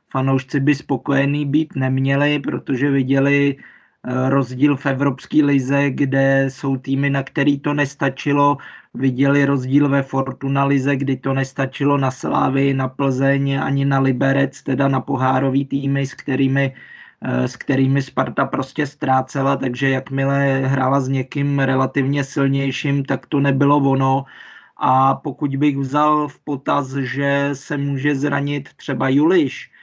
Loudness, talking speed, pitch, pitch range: -19 LUFS, 135 wpm, 140 Hz, 135-140 Hz